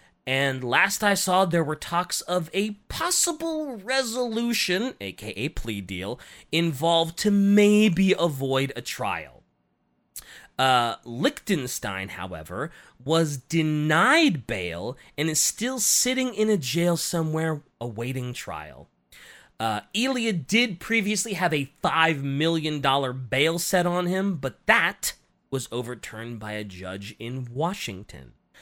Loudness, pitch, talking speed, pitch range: -24 LUFS, 160 Hz, 120 wpm, 125-195 Hz